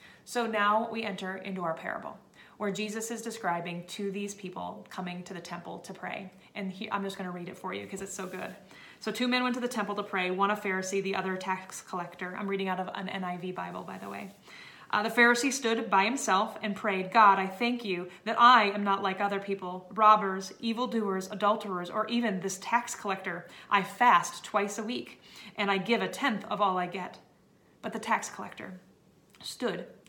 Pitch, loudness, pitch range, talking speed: 200 Hz, -29 LUFS, 185-220 Hz, 215 wpm